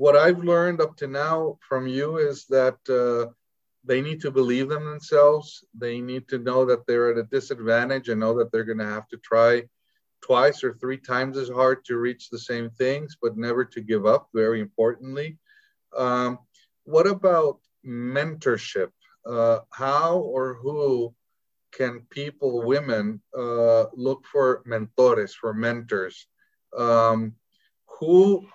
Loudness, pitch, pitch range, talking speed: -23 LUFS, 125 Hz, 115-145 Hz, 150 wpm